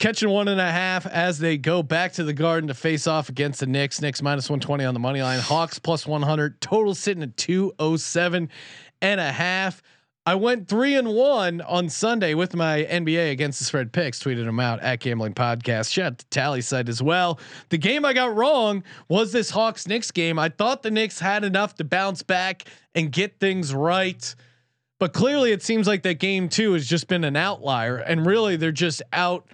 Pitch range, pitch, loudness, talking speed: 145-195 Hz, 170 Hz, -23 LUFS, 210 wpm